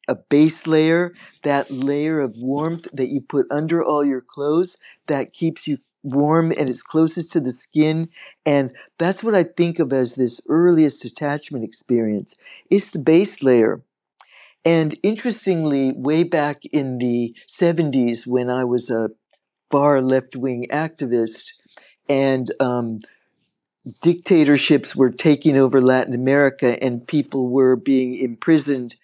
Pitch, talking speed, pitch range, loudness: 145 Hz, 140 wpm, 130-160 Hz, -19 LUFS